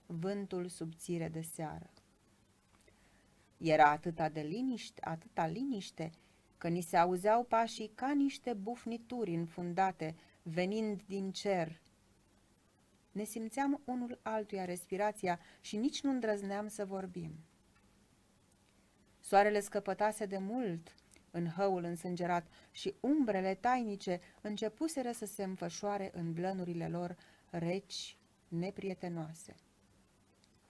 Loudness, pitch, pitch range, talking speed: -37 LUFS, 185 Hz, 165-210 Hz, 100 wpm